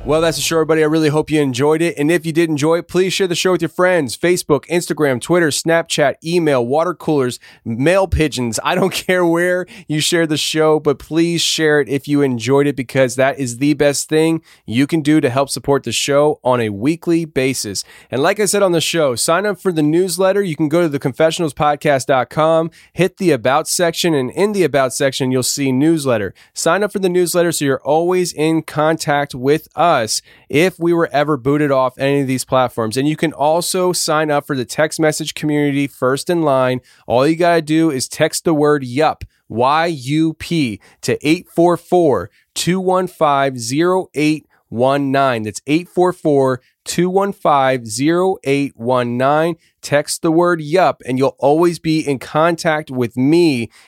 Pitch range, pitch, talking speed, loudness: 140-170 Hz, 155 Hz, 185 wpm, -16 LUFS